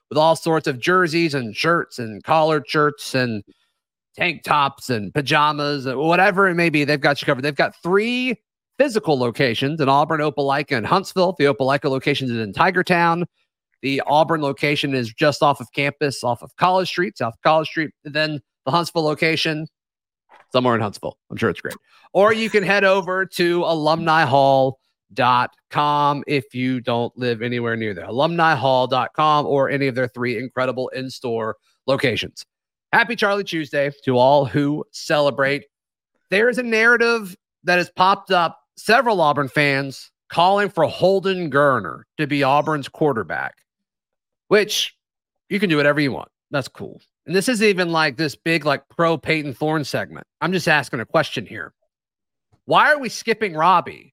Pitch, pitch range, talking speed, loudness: 150 Hz, 135-175 Hz, 170 wpm, -19 LUFS